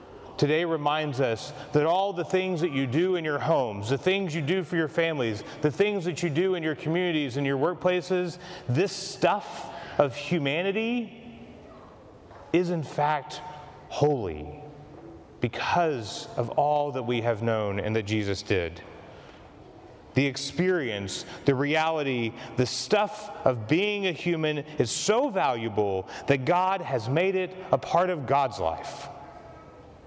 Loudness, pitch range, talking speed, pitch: -27 LUFS, 135-180 Hz, 145 wpm, 150 Hz